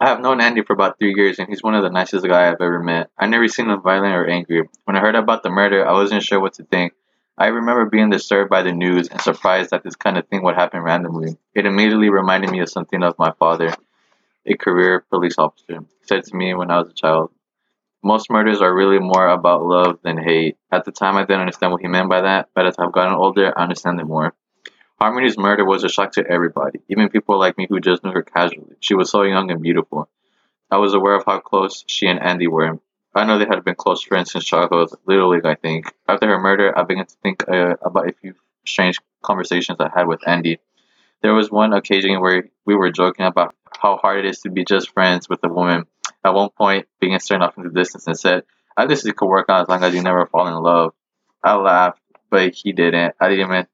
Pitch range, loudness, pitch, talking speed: 85-100 Hz, -17 LUFS, 90 Hz, 245 wpm